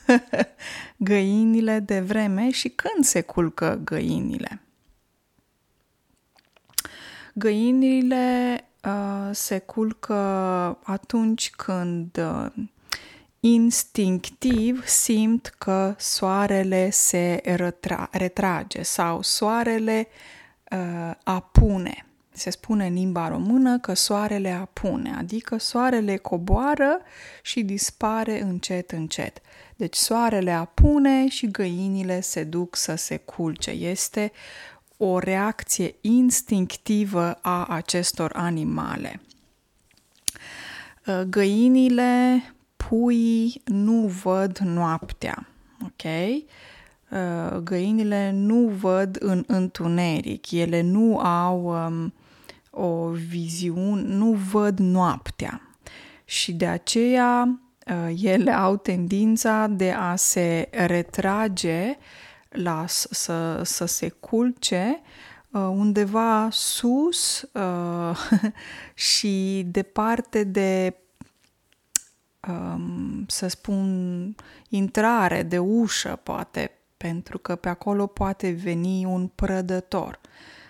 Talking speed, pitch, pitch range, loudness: 85 wpm, 195 Hz, 180-225 Hz, -23 LUFS